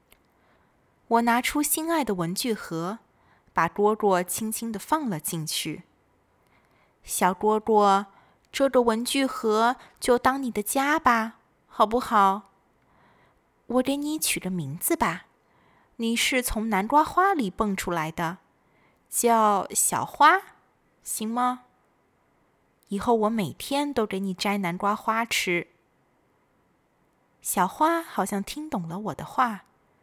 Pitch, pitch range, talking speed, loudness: 220 Hz, 190-250 Hz, 165 characters per minute, -25 LUFS